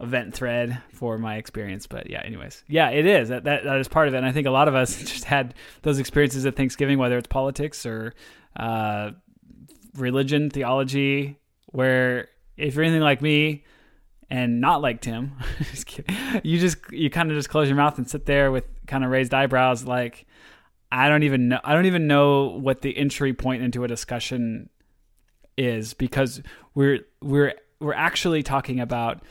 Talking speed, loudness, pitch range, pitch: 185 wpm, -23 LUFS, 125-145 Hz, 135 Hz